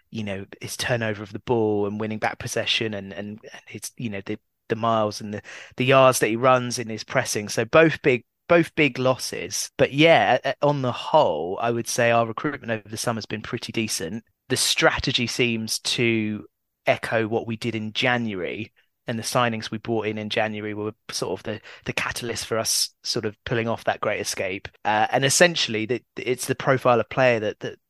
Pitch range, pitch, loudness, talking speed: 110-125 Hz, 115 Hz, -23 LUFS, 205 wpm